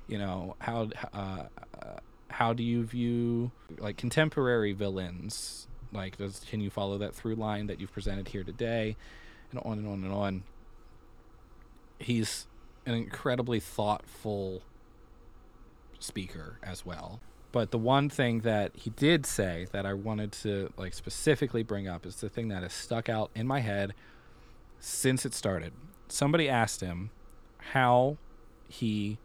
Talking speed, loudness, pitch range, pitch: 145 wpm, -32 LUFS, 100-120 Hz, 110 Hz